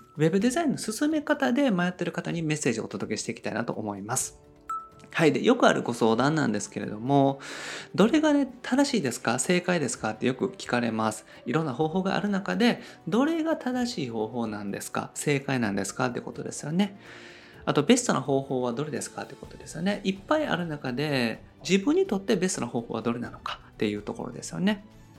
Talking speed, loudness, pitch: 430 characters per minute, -27 LUFS, 170 Hz